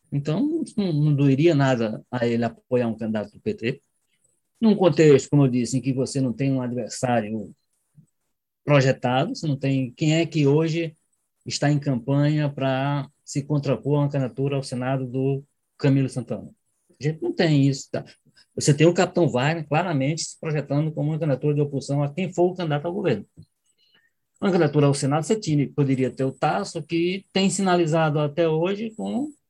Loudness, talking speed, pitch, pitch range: -23 LUFS, 175 wpm, 145 Hz, 130-165 Hz